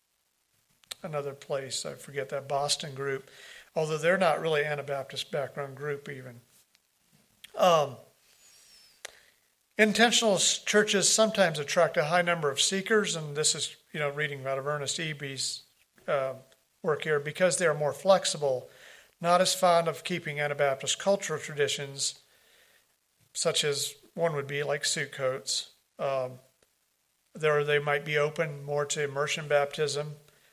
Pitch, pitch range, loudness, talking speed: 145 Hz, 140-165 Hz, -28 LUFS, 135 wpm